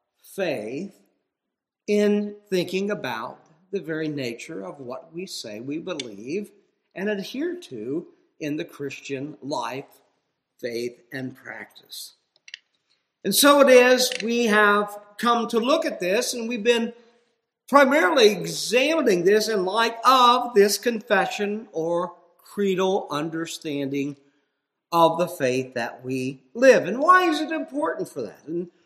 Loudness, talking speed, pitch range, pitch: -22 LUFS, 130 wpm, 160-240 Hz, 200 Hz